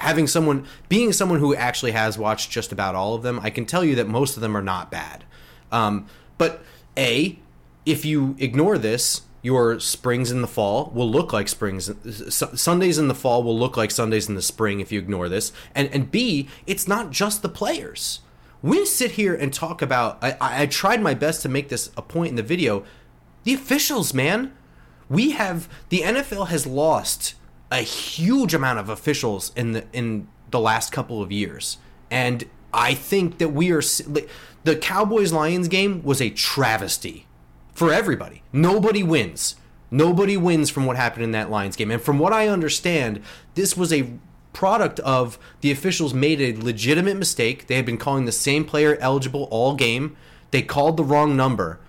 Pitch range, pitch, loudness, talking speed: 115-165 Hz, 135 Hz, -21 LUFS, 185 wpm